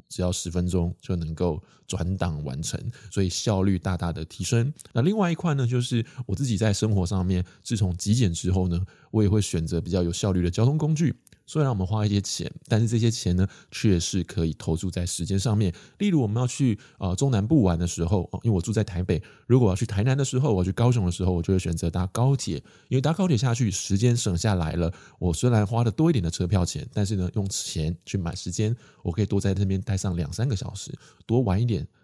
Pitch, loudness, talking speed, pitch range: 100 Hz, -25 LUFS, 345 characters per minute, 90-120 Hz